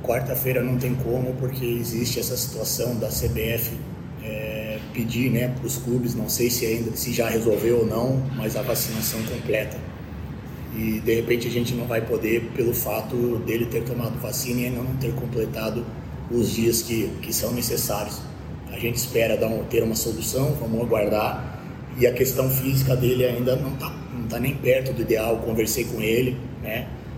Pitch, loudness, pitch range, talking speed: 120 Hz, -24 LUFS, 115-125 Hz, 180 wpm